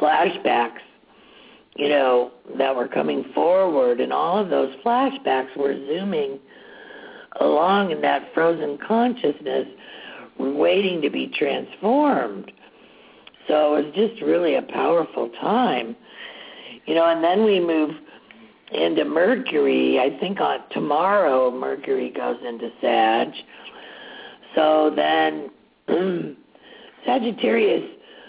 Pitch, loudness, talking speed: 165 Hz, -21 LUFS, 105 wpm